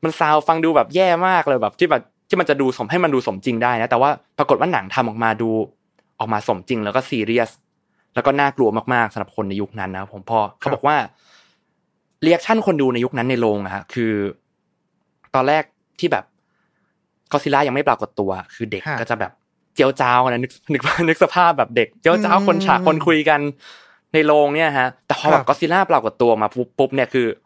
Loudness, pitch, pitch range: -18 LUFS, 130 Hz, 115-160 Hz